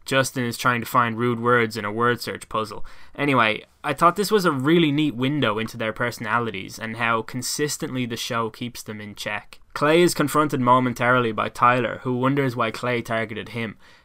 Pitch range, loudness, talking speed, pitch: 115-135 Hz, -22 LUFS, 190 wpm, 120 Hz